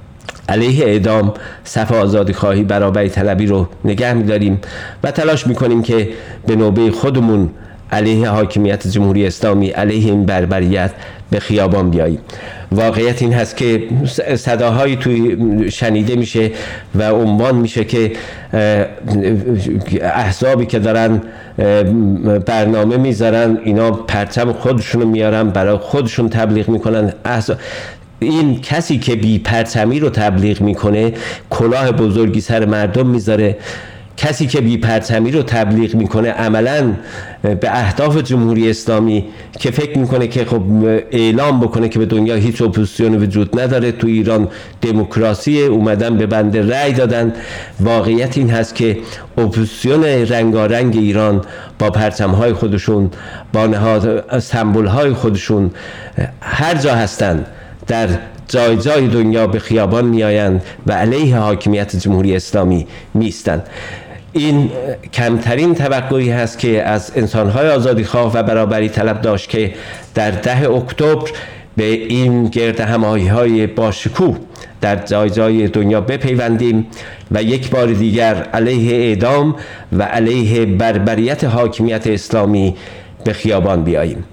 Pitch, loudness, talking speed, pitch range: 110 Hz, -14 LUFS, 120 wpm, 105-120 Hz